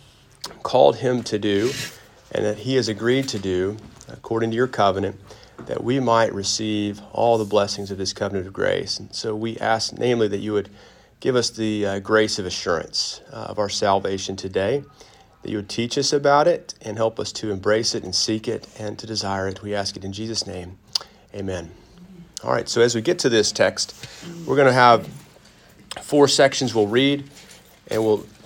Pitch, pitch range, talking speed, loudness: 110 Hz, 100-120 Hz, 195 wpm, -22 LUFS